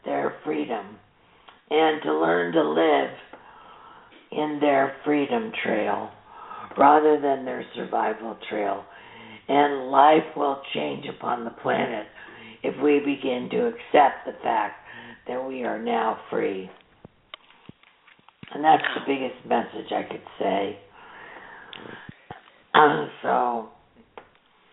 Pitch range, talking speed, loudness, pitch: 135-195 Hz, 110 wpm, -24 LUFS, 145 Hz